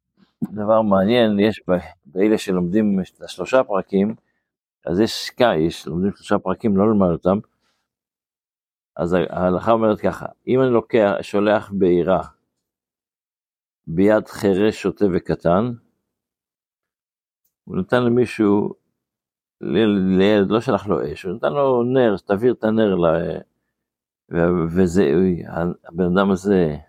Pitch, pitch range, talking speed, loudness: 100 Hz, 95-110 Hz, 115 wpm, -19 LUFS